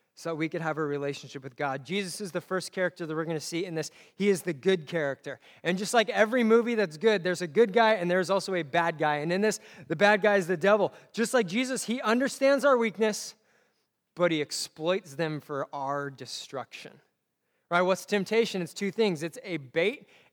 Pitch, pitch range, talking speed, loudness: 185 Hz, 160-215 Hz, 215 wpm, -28 LUFS